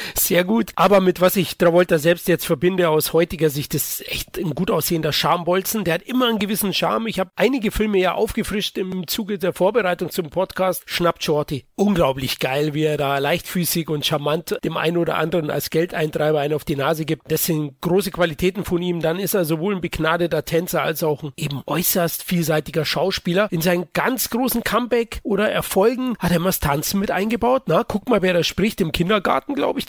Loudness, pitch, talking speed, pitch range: -20 LUFS, 175 Hz, 205 wpm, 160-195 Hz